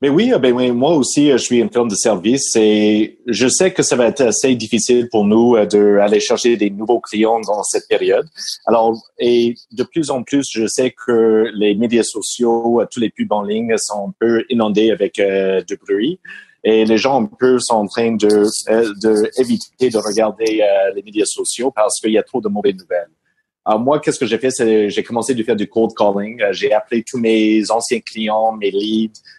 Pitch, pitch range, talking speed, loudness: 115 Hz, 110-130 Hz, 210 wpm, -15 LUFS